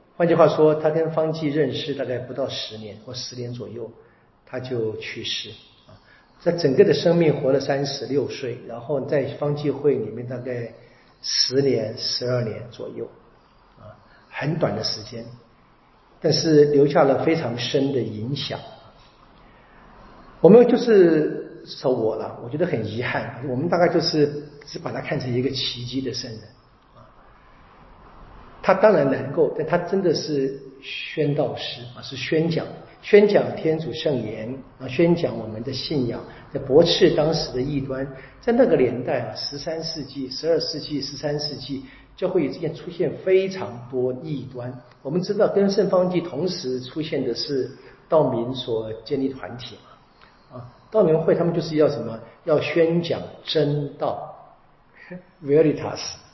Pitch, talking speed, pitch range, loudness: 140 Hz, 240 characters per minute, 125-160 Hz, -22 LUFS